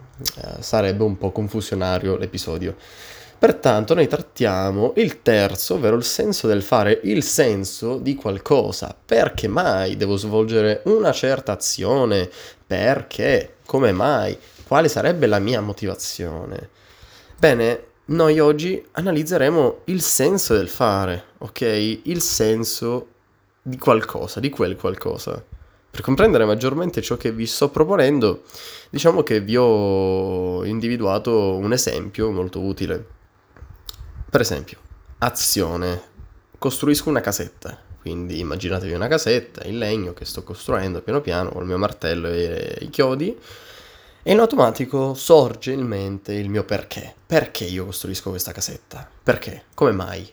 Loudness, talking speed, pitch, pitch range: -20 LUFS, 130 wpm, 105 Hz, 95-125 Hz